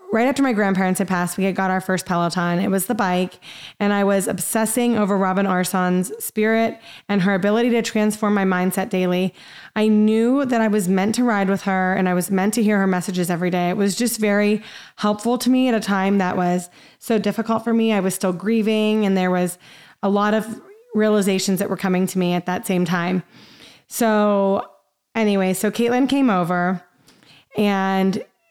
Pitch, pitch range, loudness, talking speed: 200 Hz, 185-220 Hz, -20 LUFS, 200 wpm